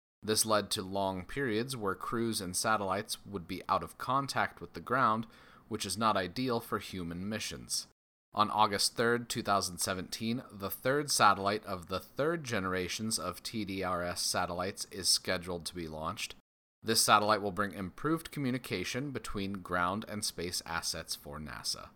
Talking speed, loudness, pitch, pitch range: 155 wpm, -33 LUFS, 100 Hz, 90-115 Hz